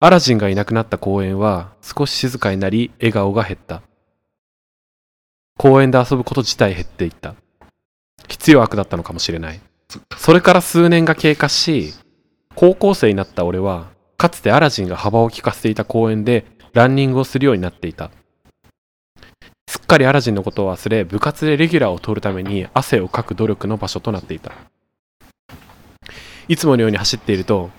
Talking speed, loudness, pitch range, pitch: 355 characters per minute, -16 LUFS, 95-135 Hz, 110 Hz